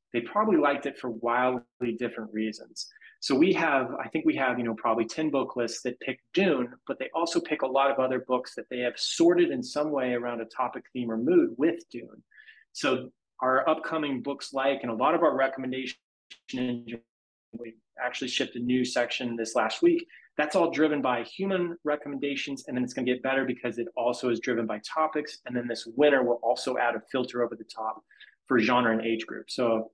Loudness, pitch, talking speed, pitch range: -28 LUFS, 125 Hz, 210 wpm, 120-150 Hz